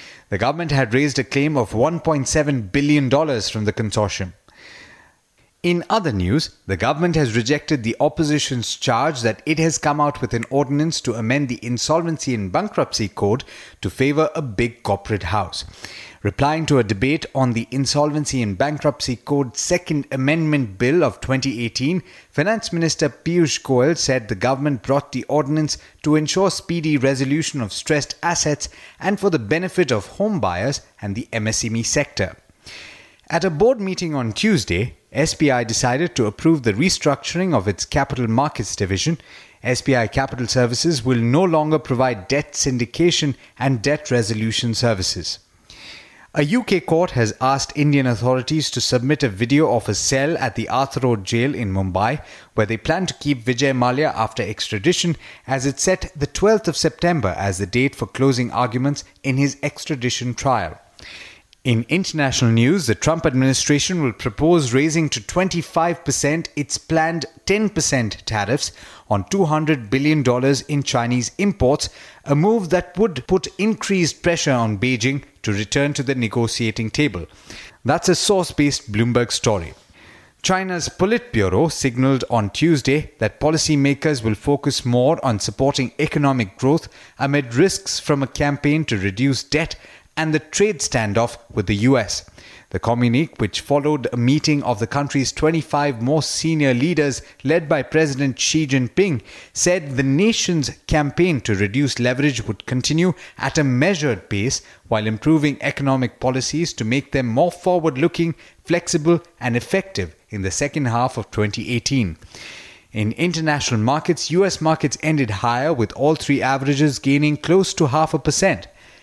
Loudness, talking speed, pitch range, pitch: -19 LUFS, 150 wpm, 120-155 Hz, 140 Hz